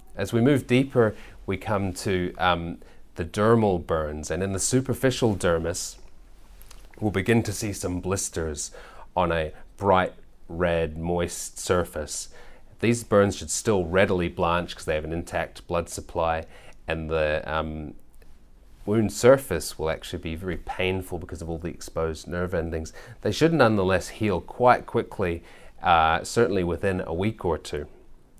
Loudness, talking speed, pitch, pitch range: -25 LUFS, 150 wpm, 90 Hz, 80-100 Hz